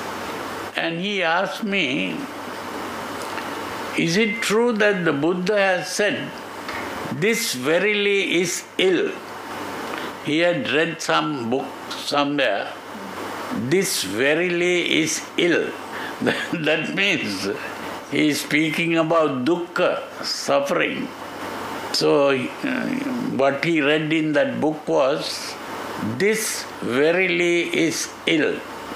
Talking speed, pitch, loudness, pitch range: 95 wpm, 175 Hz, -22 LUFS, 160-210 Hz